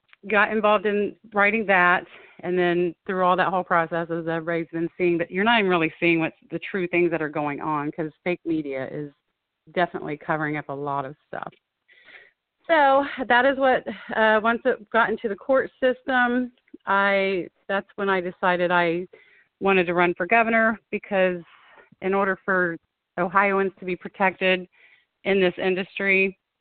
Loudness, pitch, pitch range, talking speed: -23 LUFS, 185 Hz, 170-205 Hz, 170 wpm